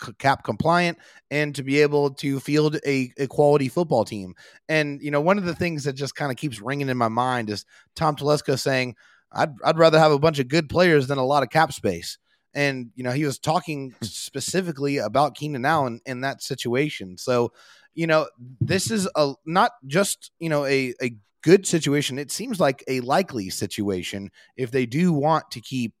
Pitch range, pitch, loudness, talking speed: 130-155 Hz, 140 Hz, -23 LUFS, 200 wpm